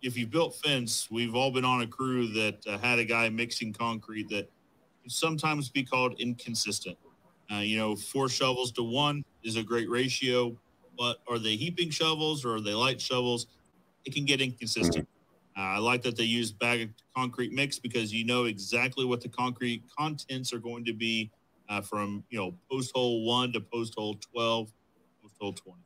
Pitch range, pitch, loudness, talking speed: 110-130 Hz, 120 Hz, -30 LUFS, 195 wpm